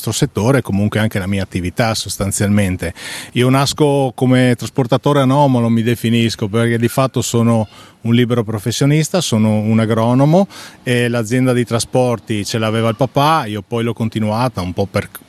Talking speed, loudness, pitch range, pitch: 155 wpm, -15 LUFS, 110-130 Hz, 115 Hz